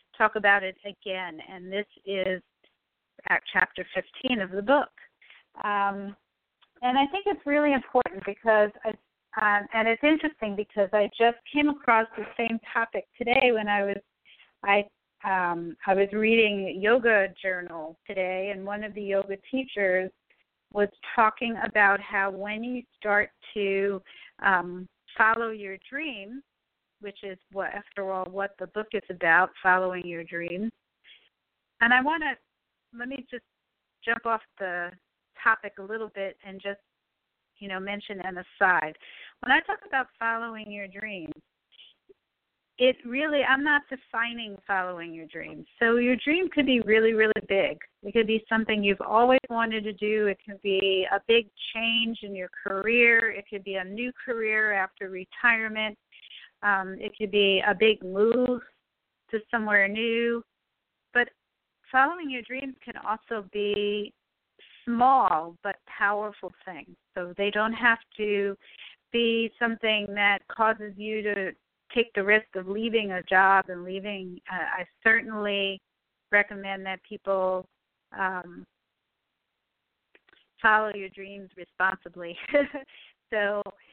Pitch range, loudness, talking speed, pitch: 195-230 Hz, -26 LUFS, 145 wpm, 210 Hz